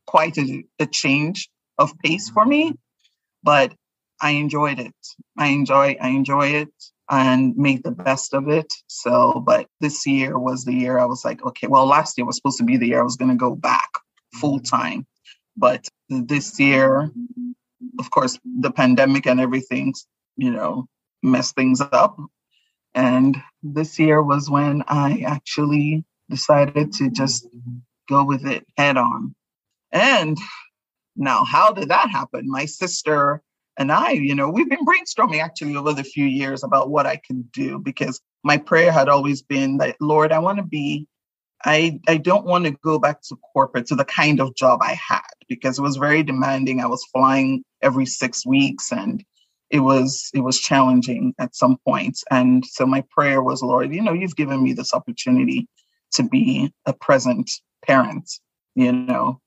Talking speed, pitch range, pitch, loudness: 175 wpm, 130-155 Hz, 140 Hz, -19 LUFS